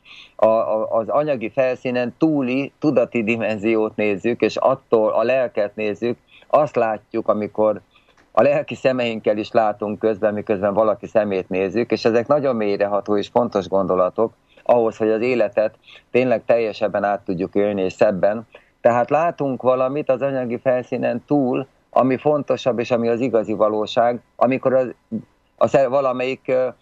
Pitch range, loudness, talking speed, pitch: 105-125 Hz, -20 LUFS, 135 wpm, 115 Hz